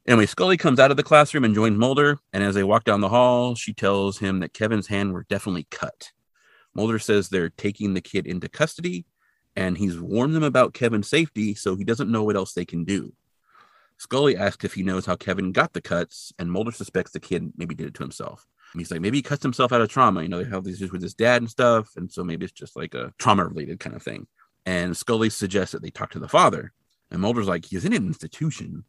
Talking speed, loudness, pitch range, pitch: 245 wpm, -23 LUFS, 95-120 Hz, 105 Hz